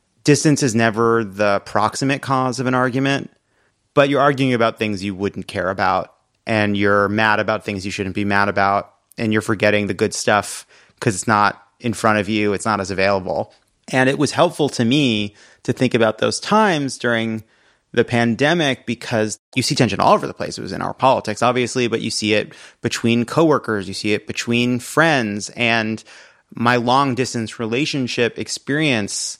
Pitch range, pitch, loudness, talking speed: 105-130 Hz, 115 Hz, -18 LUFS, 185 wpm